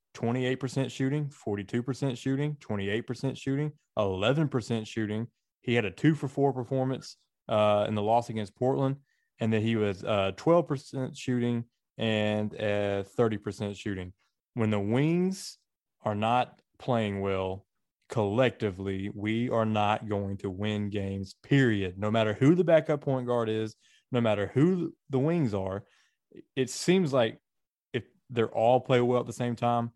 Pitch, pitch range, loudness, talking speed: 120 Hz, 105-135 Hz, -29 LUFS, 150 wpm